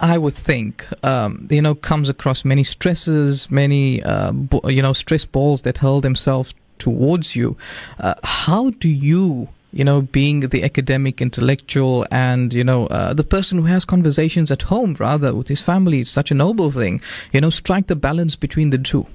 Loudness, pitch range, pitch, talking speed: -17 LUFS, 130-160 Hz, 140 Hz, 190 wpm